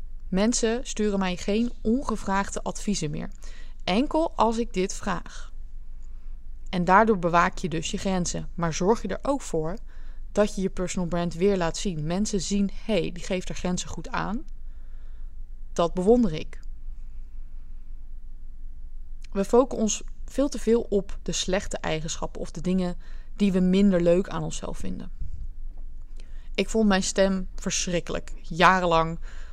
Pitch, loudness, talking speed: 180 Hz, -26 LUFS, 145 wpm